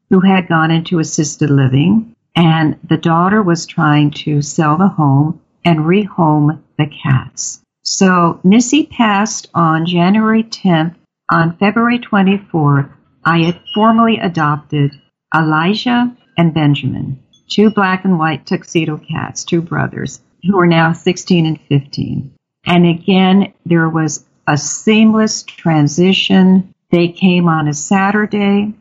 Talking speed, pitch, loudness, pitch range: 125 wpm, 170 Hz, -13 LUFS, 155-195 Hz